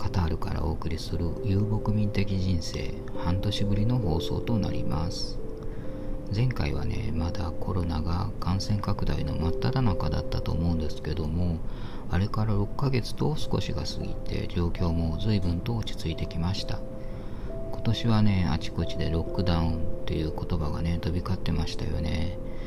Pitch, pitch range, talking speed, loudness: 95 Hz, 85-105 Hz, 335 characters per minute, -30 LUFS